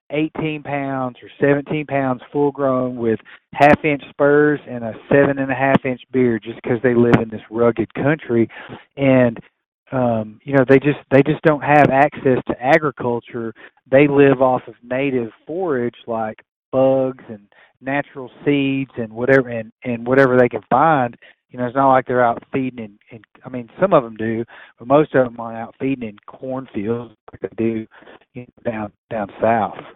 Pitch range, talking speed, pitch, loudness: 115-140 Hz, 170 wpm, 130 Hz, -18 LUFS